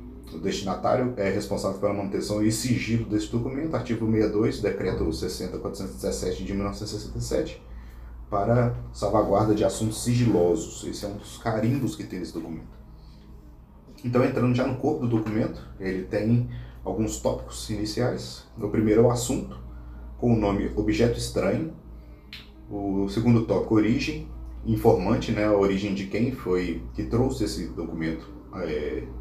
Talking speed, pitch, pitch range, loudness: 140 wpm, 105 Hz, 85-115 Hz, -26 LUFS